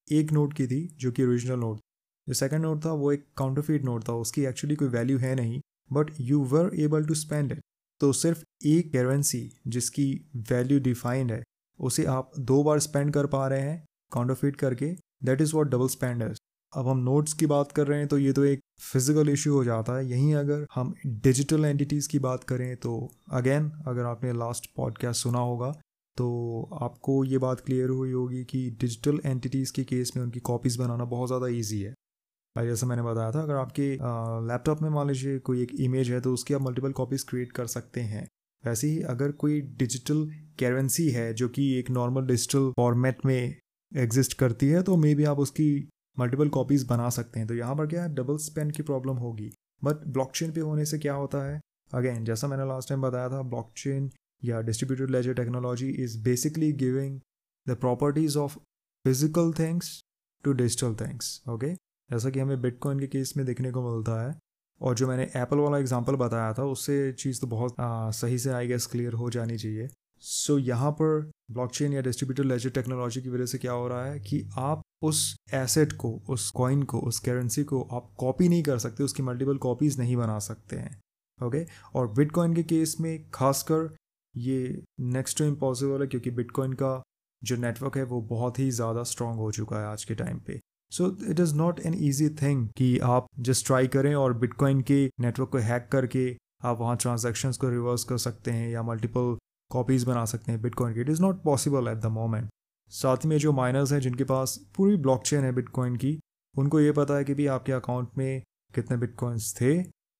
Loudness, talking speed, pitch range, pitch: -28 LUFS, 200 wpm, 125-145 Hz, 130 Hz